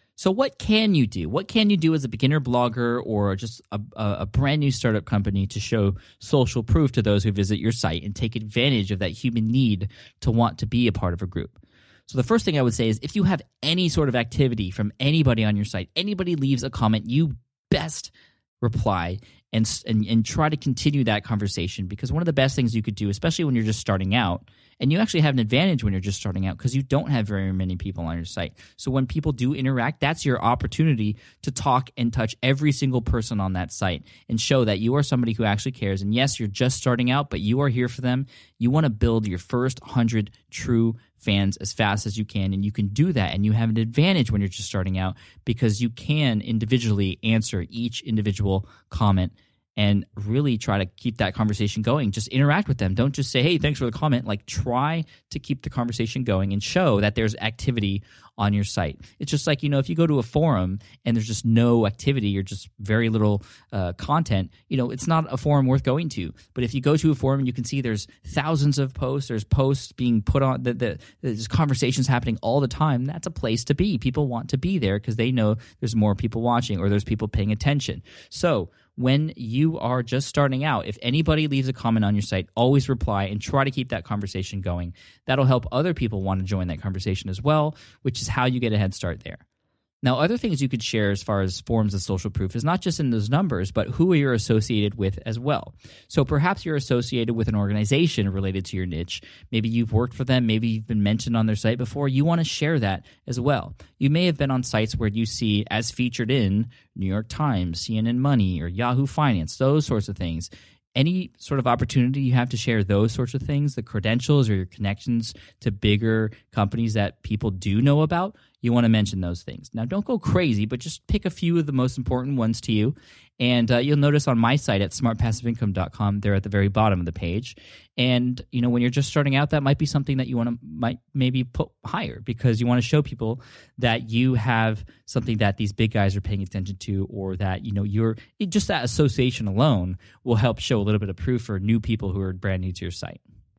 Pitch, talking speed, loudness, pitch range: 115 Hz, 235 wpm, -23 LUFS, 105-135 Hz